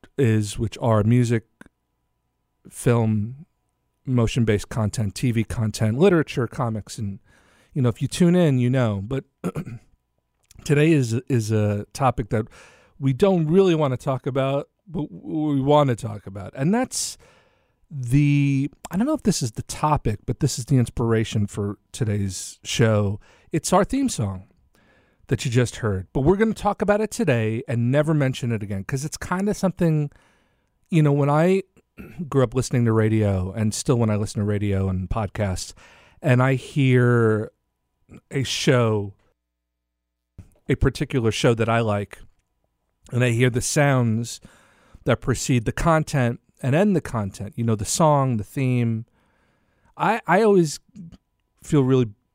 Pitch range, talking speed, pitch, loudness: 105-145 Hz, 160 wpm, 125 Hz, -22 LUFS